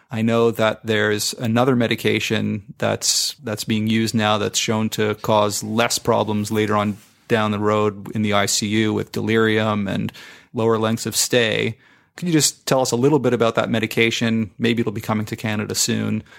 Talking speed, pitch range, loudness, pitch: 190 wpm, 105-115 Hz, -20 LUFS, 110 Hz